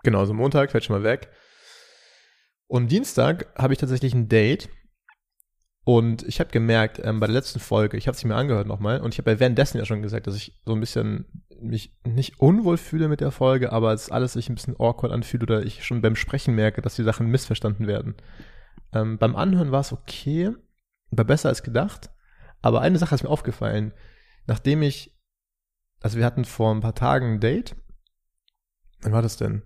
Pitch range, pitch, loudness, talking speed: 110-130 Hz, 115 Hz, -23 LUFS, 210 wpm